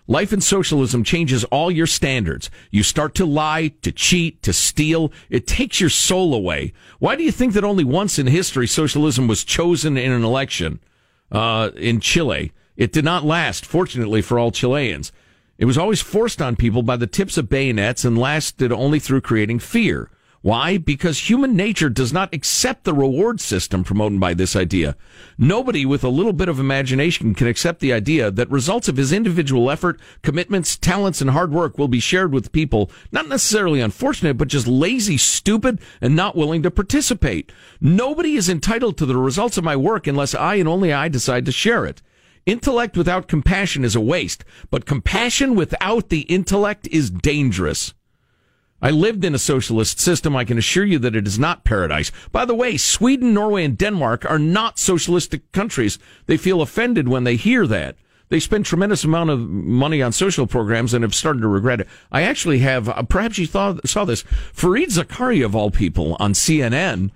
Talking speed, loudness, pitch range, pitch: 190 wpm, -18 LUFS, 120-185 Hz, 150 Hz